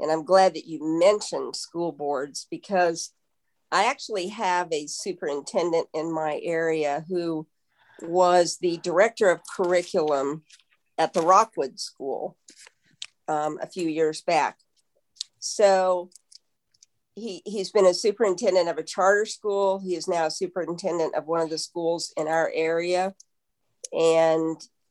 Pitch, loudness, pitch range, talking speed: 170 Hz, -25 LUFS, 160-185 Hz, 135 wpm